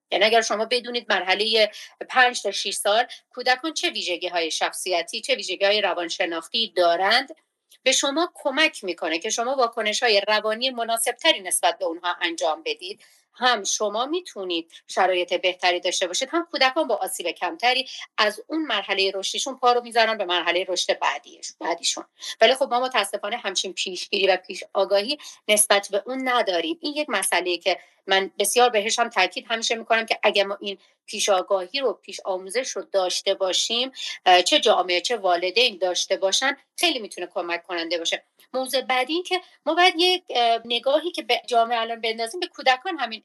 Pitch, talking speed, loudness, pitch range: 215 Hz, 165 wpm, -22 LUFS, 190-255 Hz